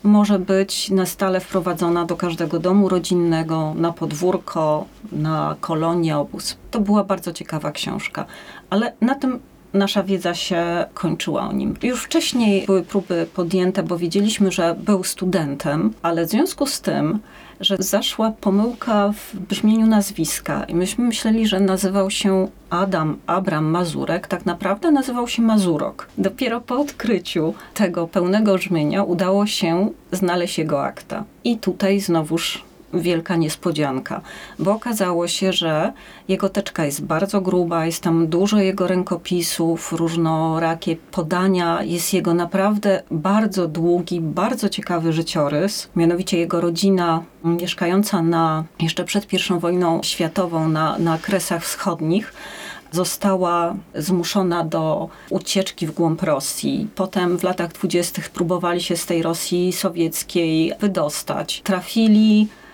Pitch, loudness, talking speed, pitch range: 180 Hz, -20 LUFS, 130 wpm, 170-200 Hz